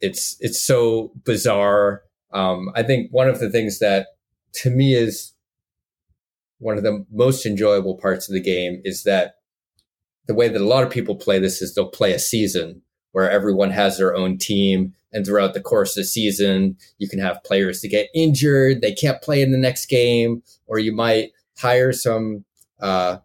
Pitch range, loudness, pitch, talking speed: 95-120 Hz, -19 LUFS, 105 Hz, 190 wpm